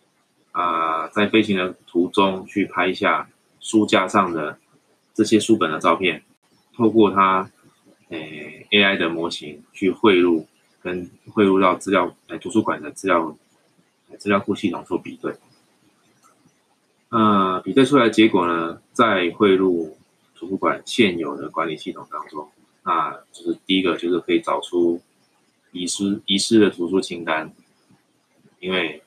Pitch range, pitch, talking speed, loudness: 85-105 Hz, 95 Hz, 215 characters per minute, -20 LUFS